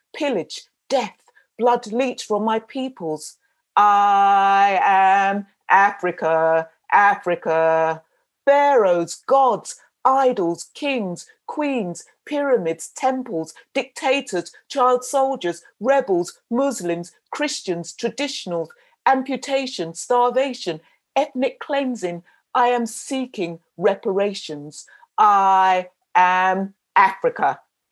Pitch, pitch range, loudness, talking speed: 225 Hz, 175-270 Hz, -20 LUFS, 75 wpm